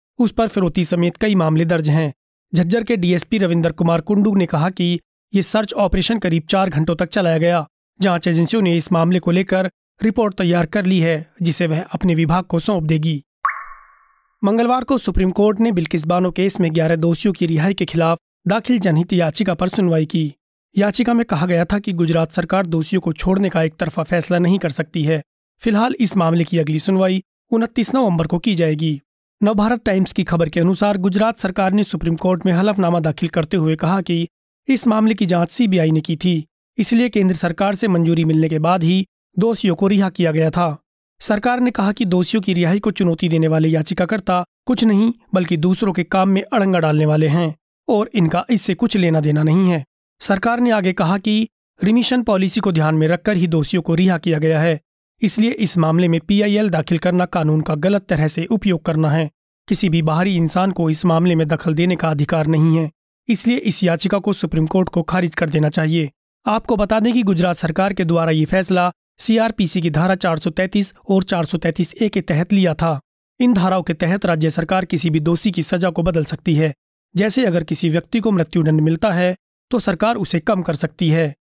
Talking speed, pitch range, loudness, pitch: 205 wpm, 165-200 Hz, -17 LUFS, 180 Hz